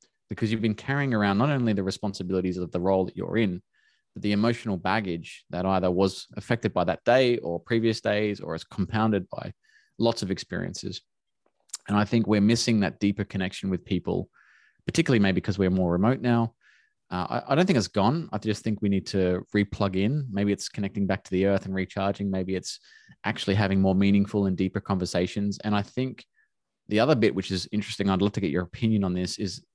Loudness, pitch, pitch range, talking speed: -26 LUFS, 100 Hz, 95-110 Hz, 210 wpm